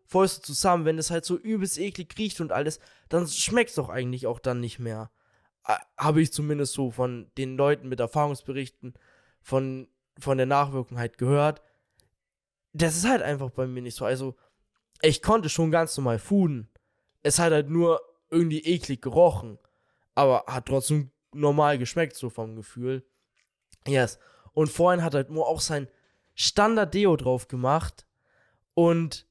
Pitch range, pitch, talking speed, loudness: 125-165 Hz, 140 Hz, 160 wpm, -26 LUFS